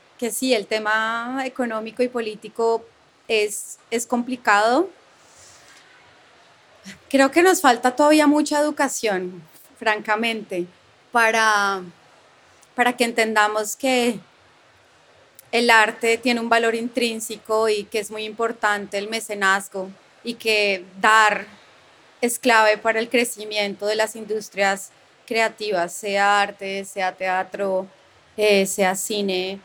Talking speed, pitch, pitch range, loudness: 110 wpm, 220 Hz, 200-235 Hz, -20 LUFS